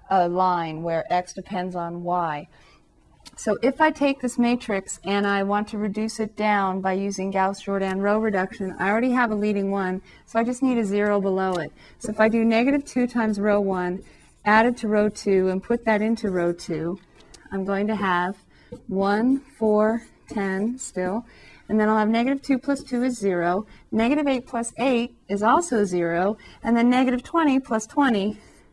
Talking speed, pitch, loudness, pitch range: 190 wpm, 210 Hz, -23 LUFS, 190-235 Hz